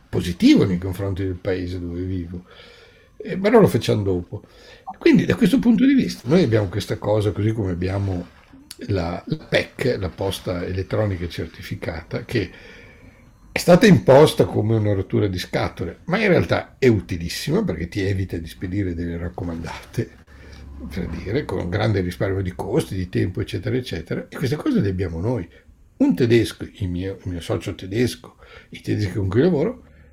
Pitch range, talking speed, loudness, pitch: 90-110 Hz, 165 wpm, -21 LUFS, 95 Hz